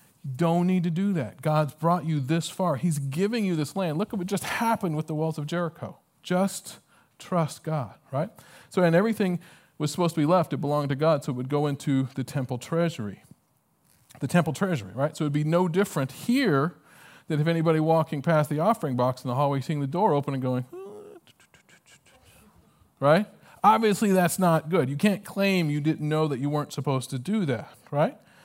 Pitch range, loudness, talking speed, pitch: 145-180 Hz, -26 LUFS, 205 wpm, 160 Hz